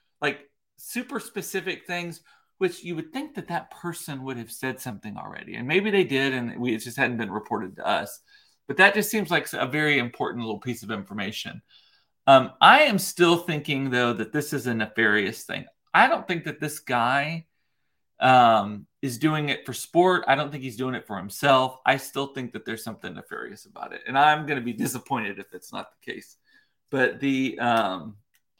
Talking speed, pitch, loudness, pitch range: 200 wpm, 140 Hz, -24 LUFS, 125-175 Hz